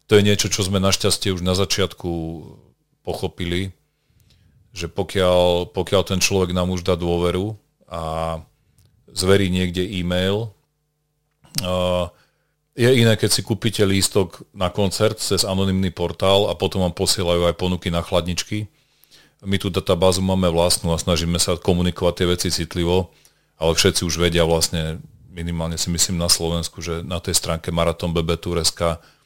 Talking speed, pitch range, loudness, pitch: 145 wpm, 85-100 Hz, -20 LUFS, 90 Hz